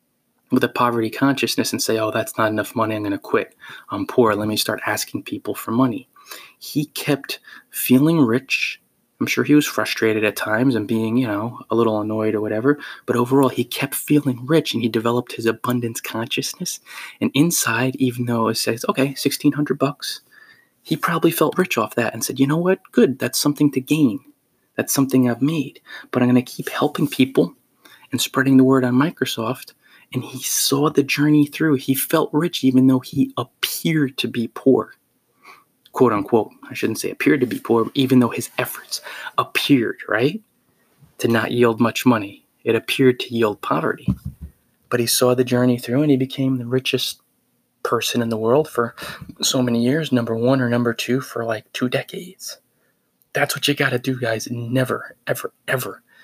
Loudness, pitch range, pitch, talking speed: -20 LUFS, 115-140 Hz, 125 Hz, 190 wpm